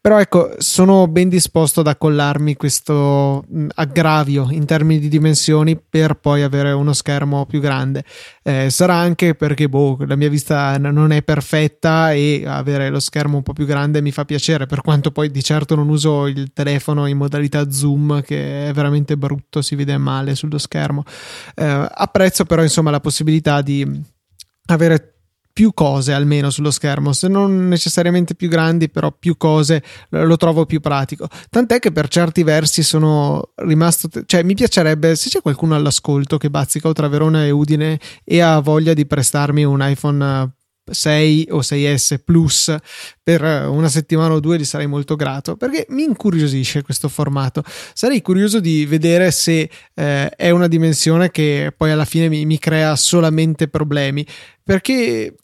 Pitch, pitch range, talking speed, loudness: 150 Hz, 145-165 Hz, 165 wpm, -15 LUFS